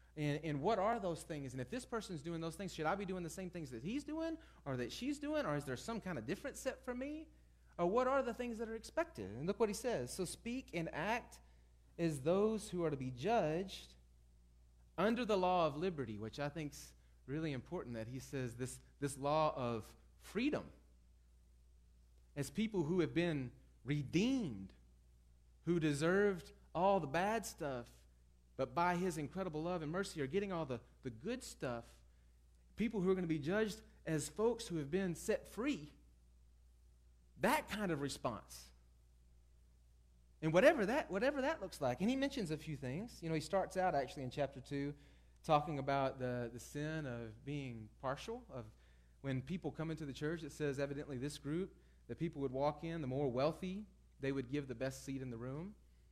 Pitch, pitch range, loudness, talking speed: 150 Hz, 120-185 Hz, -40 LUFS, 195 wpm